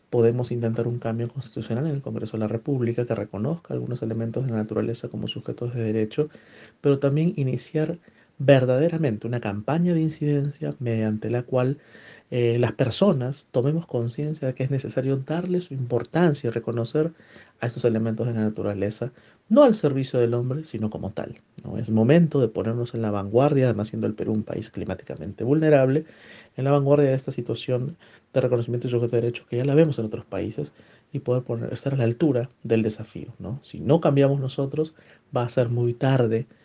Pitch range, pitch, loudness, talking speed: 115-140 Hz, 120 Hz, -24 LUFS, 190 wpm